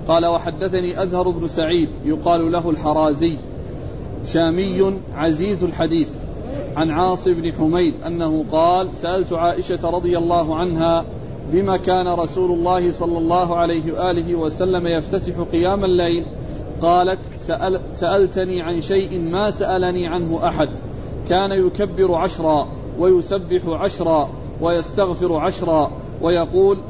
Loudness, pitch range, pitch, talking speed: -19 LUFS, 165-180 Hz, 170 Hz, 115 wpm